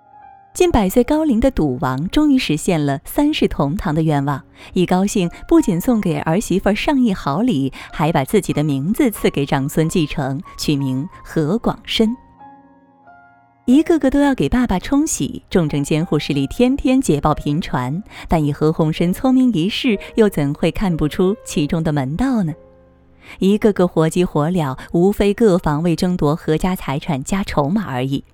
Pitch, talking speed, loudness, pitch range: 175 Hz, 250 characters per minute, -18 LUFS, 145-225 Hz